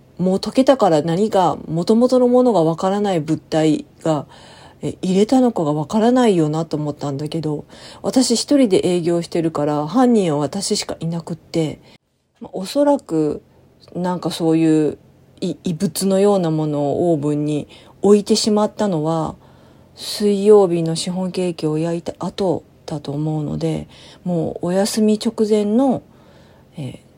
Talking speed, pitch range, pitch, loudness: 295 characters per minute, 155-210 Hz, 175 Hz, -18 LUFS